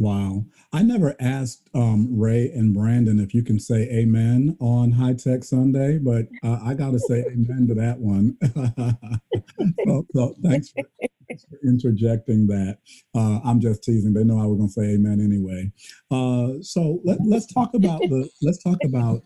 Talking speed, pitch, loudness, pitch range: 180 wpm, 120 Hz, -21 LUFS, 110-135 Hz